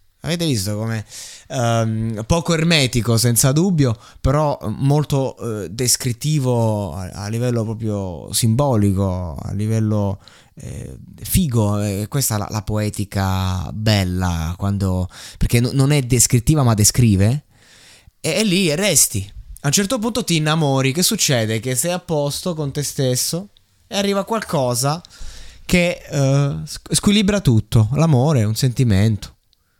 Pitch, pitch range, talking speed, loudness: 120 Hz, 105-145 Hz, 130 wpm, -18 LUFS